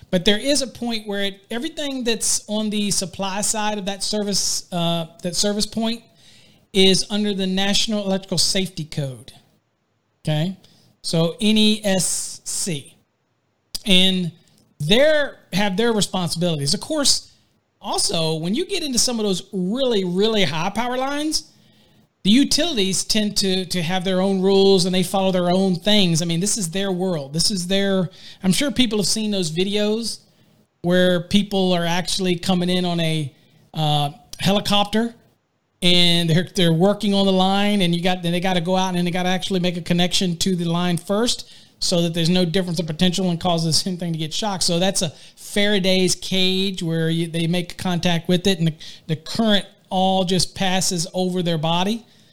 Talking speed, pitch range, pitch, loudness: 175 wpm, 175-205 Hz, 185 Hz, -20 LUFS